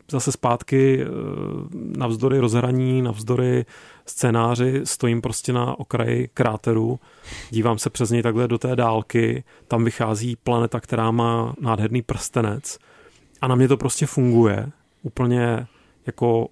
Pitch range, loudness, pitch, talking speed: 115-125 Hz, -22 LUFS, 120 Hz, 125 wpm